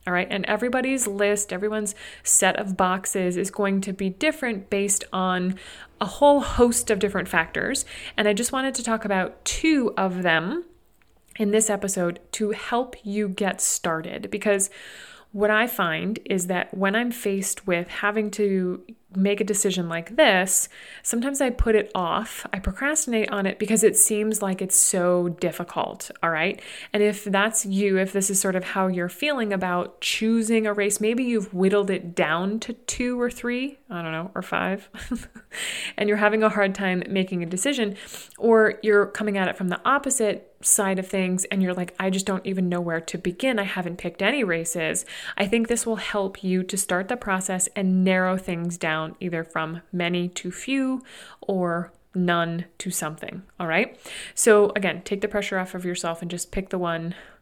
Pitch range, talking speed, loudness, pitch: 185-215 Hz, 185 wpm, -23 LUFS, 195 Hz